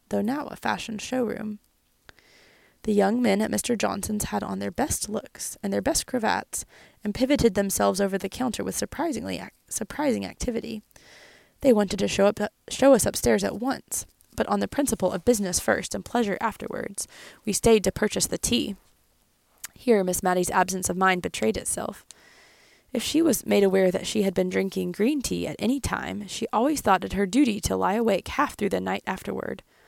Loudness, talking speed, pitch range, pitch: -25 LUFS, 190 wpm, 190-240 Hz, 210 Hz